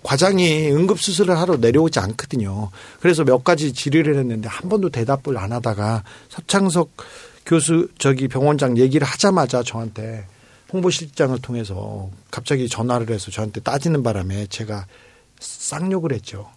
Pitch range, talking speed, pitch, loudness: 110-165 Hz, 335 characters per minute, 130 Hz, -19 LUFS